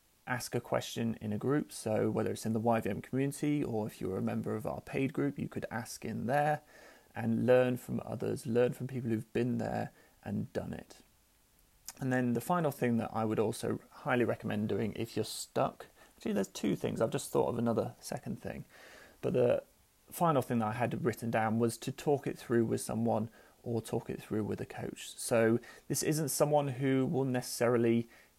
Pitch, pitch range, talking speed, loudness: 115 Hz, 110-130 Hz, 205 wpm, -34 LUFS